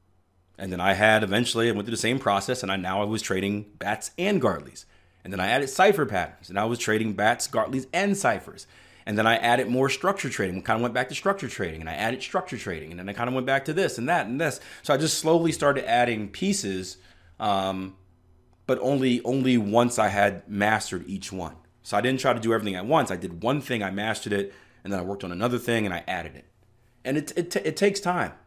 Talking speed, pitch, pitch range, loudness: 250 wpm, 110 Hz, 95-130 Hz, -25 LUFS